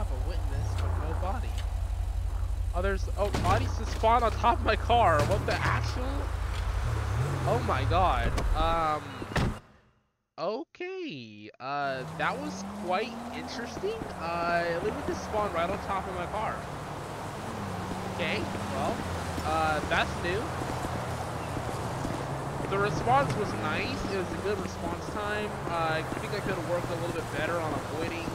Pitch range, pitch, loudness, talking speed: 85-120 Hz, 100 Hz, -30 LUFS, 140 wpm